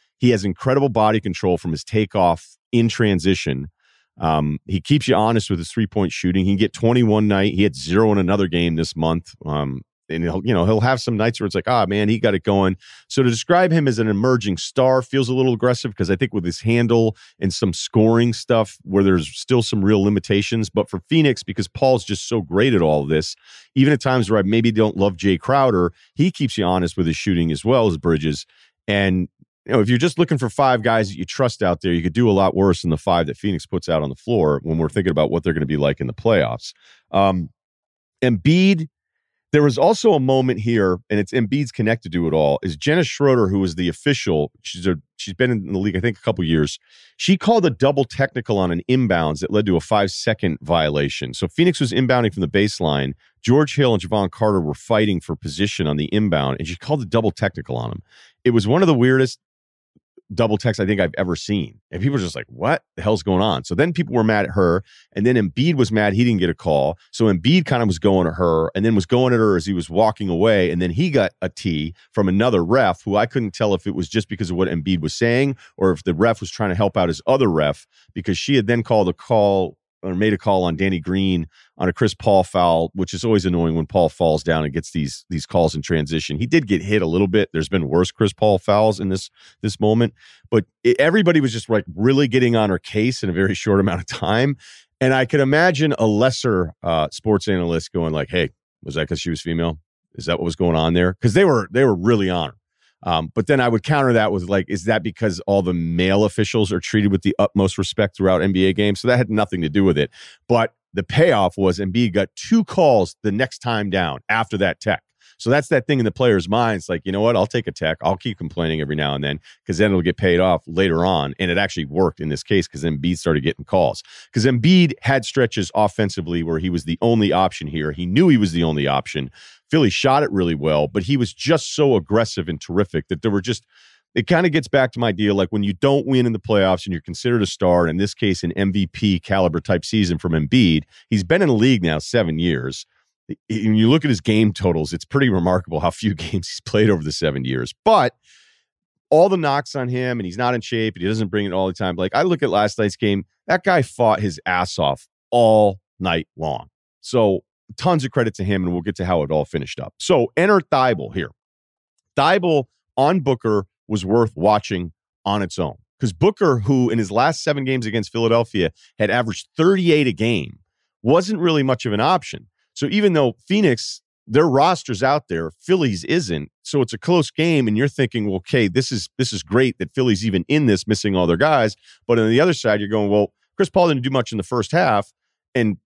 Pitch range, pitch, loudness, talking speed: 90-120 Hz, 100 Hz, -19 LUFS, 240 wpm